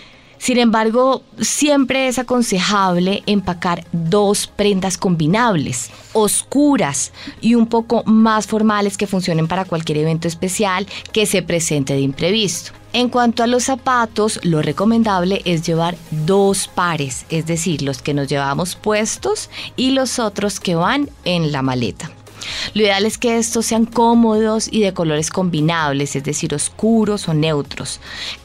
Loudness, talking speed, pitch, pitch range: -17 LUFS, 145 wpm, 195 Hz, 160-225 Hz